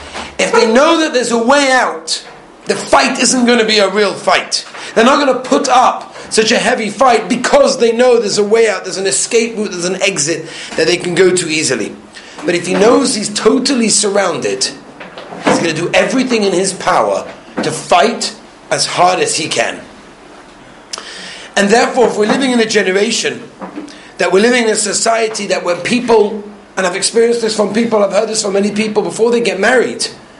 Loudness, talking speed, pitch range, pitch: -12 LUFS, 200 wpm, 195-245 Hz, 220 Hz